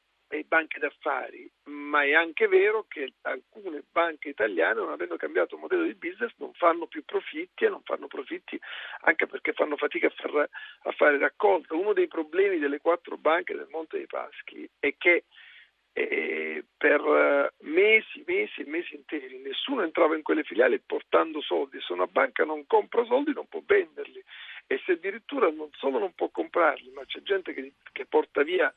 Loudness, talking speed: -27 LUFS, 175 wpm